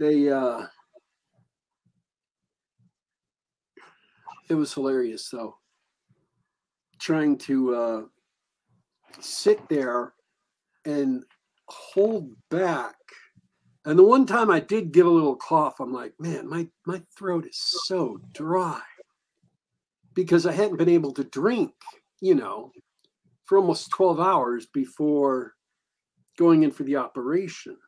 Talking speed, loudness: 110 wpm, -24 LUFS